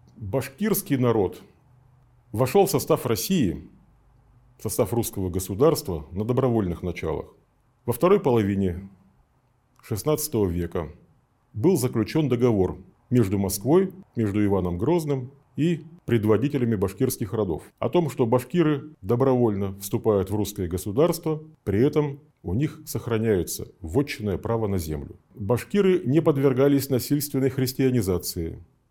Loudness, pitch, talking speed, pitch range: -24 LUFS, 125 Hz, 110 wpm, 105-145 Hz